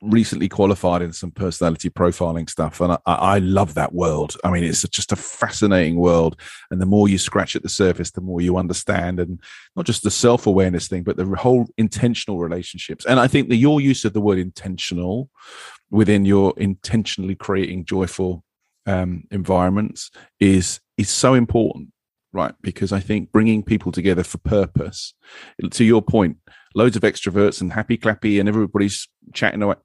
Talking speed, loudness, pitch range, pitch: 175 wpm, -19 LUFS, 90-105 Hz, 95 Hz